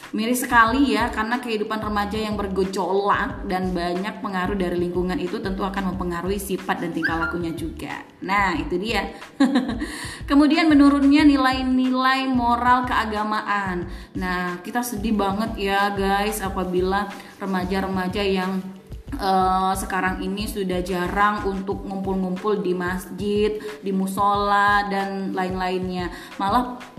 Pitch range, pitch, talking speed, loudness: 185-225 Hz, 200 Hz, 120 wpm, -22 LUFS